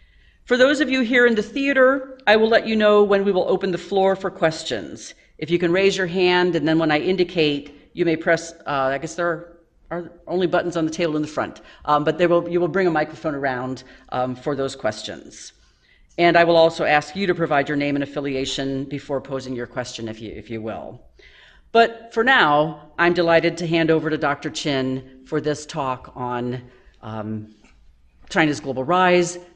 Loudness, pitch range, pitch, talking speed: -20 LUFS, 135-180 Hz, 160 Hz, 205 wpm